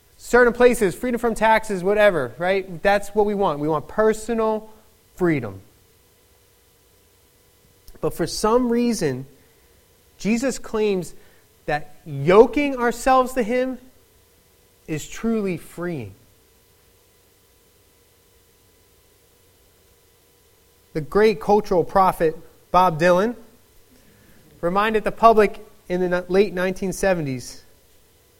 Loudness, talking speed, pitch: -20 LUFS, 90 wpm, 180 Hz